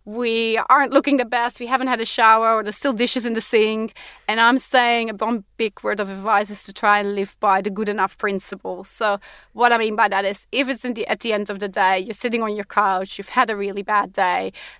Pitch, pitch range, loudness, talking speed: 220 Hz, 205-240 Hz, -20 LUFS, 260 wpm